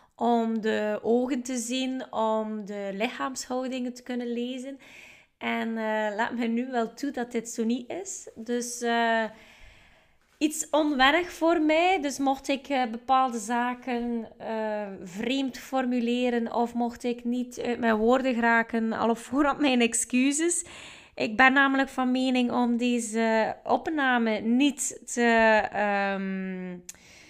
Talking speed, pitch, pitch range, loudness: 135 wpm, 240 Hz, 225-265 Hz, -26 LUFS